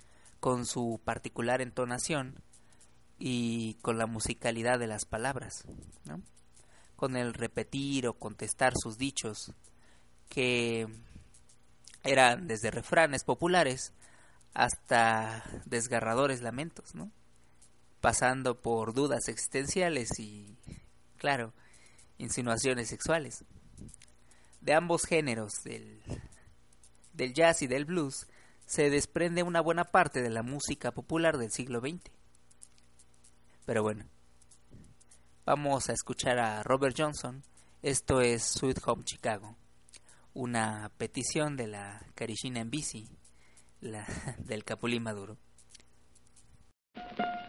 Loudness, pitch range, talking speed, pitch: -32 LUFS, 85-130 Hz, 100 wpm, 115 Hz